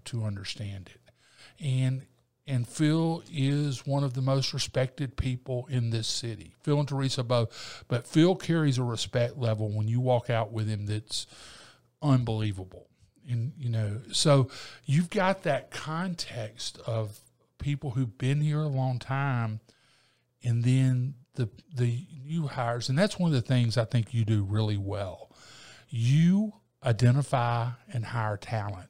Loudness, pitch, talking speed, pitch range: -29 LUFS, 125 Hz, 150 wpm, 115-140 Hz